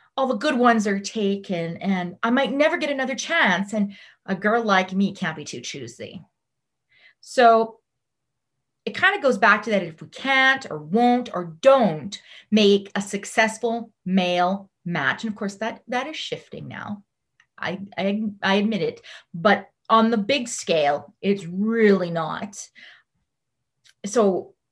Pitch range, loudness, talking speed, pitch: 190-240 Hz, -22 LUFS, 155 wpm, 210 Hz